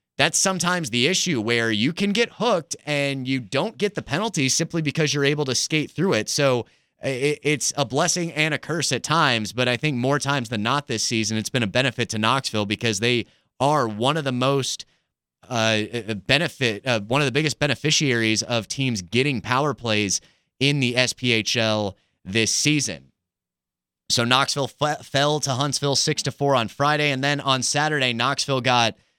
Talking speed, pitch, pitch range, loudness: 185 wpm, 135 Hz, 115-145 Hz, -22 LUFS